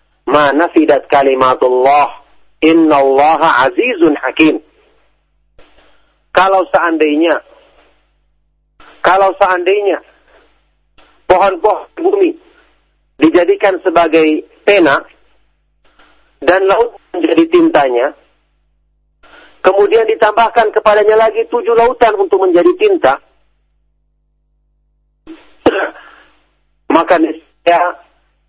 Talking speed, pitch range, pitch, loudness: 60 wpm, 145-215 Hz, 175 Hz, -11 LUFS